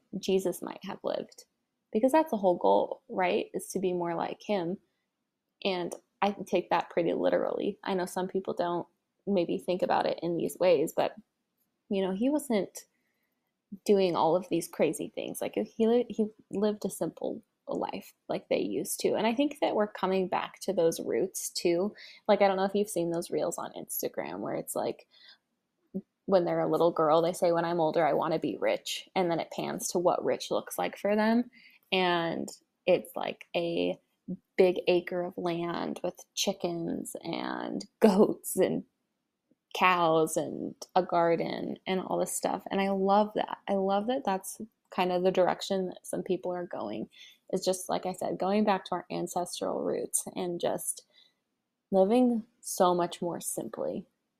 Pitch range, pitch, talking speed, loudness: 175-215 Hz, 190 Hz, 180 wpm, -30 LUFS